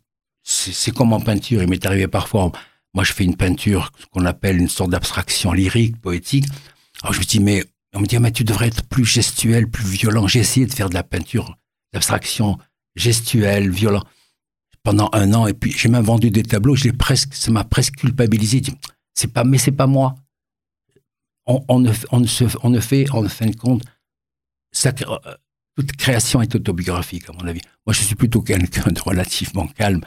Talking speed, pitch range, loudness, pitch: 210 wpm, 95-125 Hz, -18 LUFS, 110 Hz